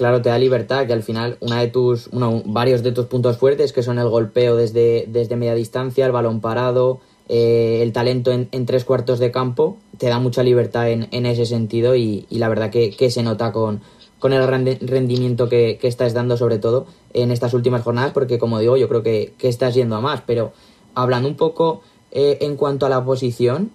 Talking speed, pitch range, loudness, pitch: 220 wpm, 115-130 Hz, -18 LUFS, 125 Hz